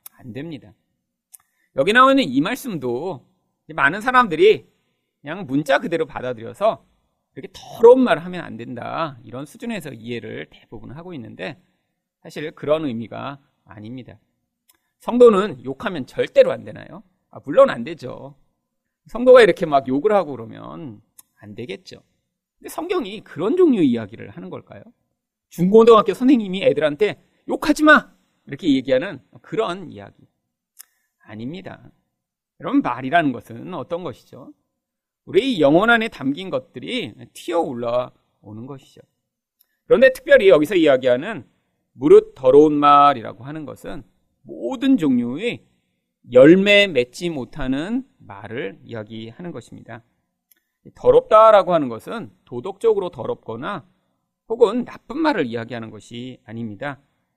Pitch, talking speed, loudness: 165 Hz, 295 characters per minute, -17 LUFS